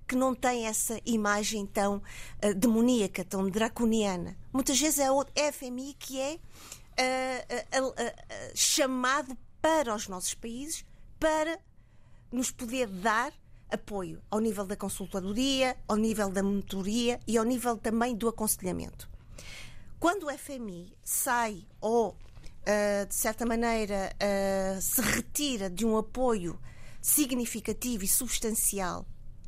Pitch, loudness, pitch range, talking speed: 225 Hz, -30 LUFS, 200-255 Hz, 130 wpm